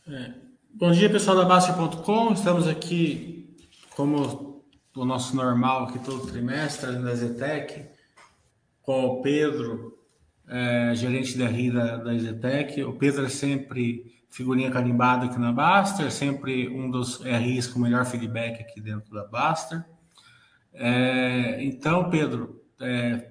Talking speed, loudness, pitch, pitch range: 135 wpm, -25 LUFS, 130 Hz, 120-150 Hz